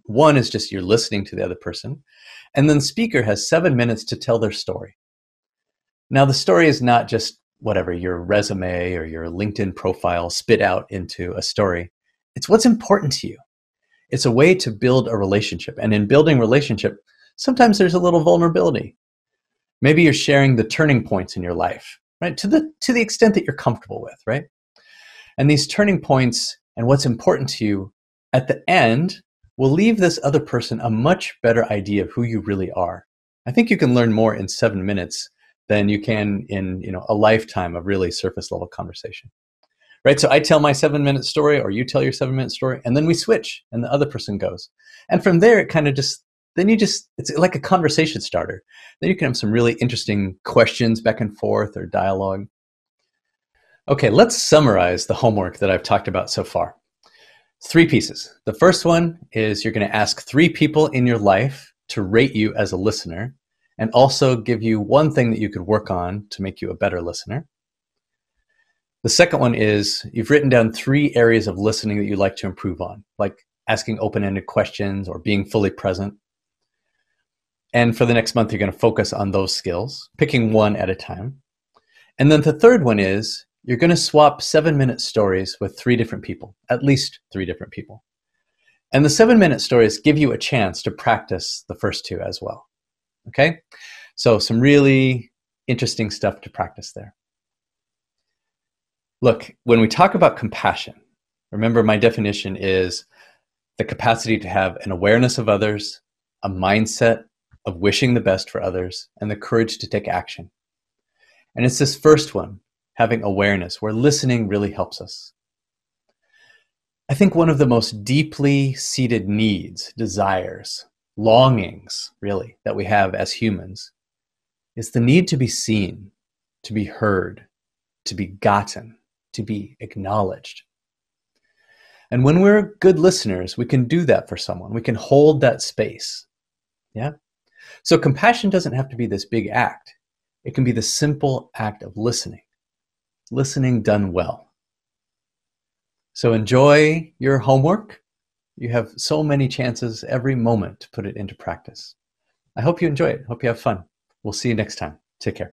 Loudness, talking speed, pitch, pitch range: -18 LUFS, 180 wpm, 115 Hz, 105-145 Hz